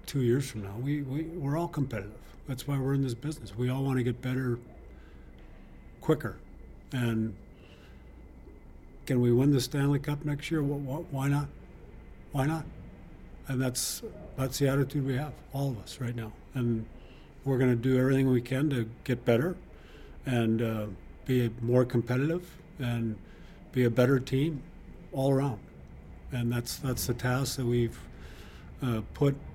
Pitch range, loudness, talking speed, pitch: 110-140 Hz, -30 LUFS, 160 wpm, 125 Hz